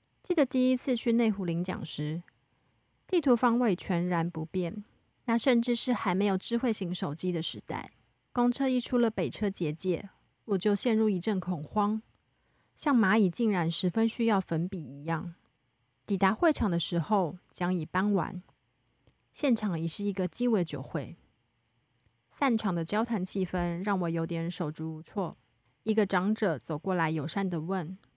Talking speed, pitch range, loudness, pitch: 235 characters per minute, 165-220 Hz, -30 LUFS, 185 Hz